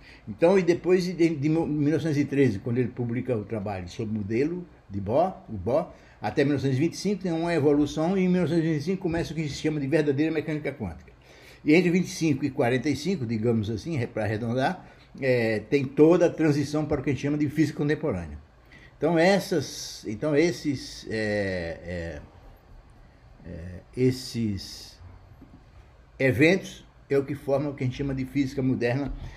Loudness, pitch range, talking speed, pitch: -26 LUFS, 115-155 Hz, 160 wpm, 140 Hz